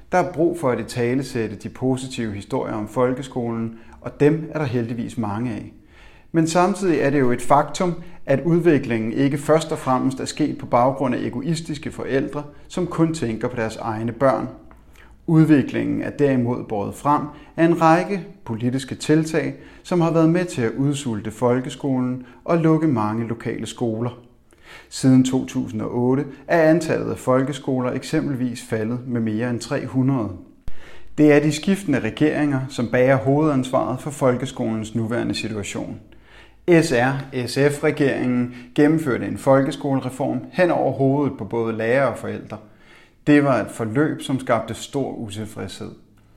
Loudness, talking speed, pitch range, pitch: -21 LUFS, 145 wpm, 115-150 Hz, 130 Hz